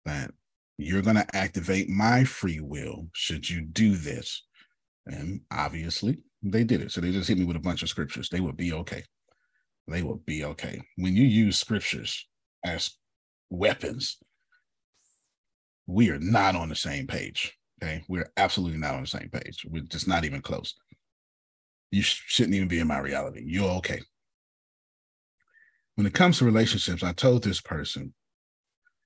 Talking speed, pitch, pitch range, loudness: 165 wpm, 95 Hz, 85-110 Hz, -27 LUFS